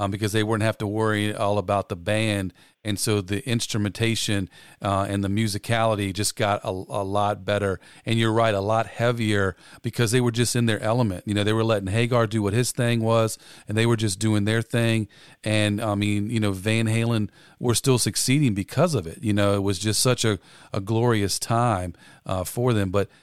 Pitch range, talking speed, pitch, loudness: 100-115 Hz, 215 wpm, 110 Hz, -24 LUFS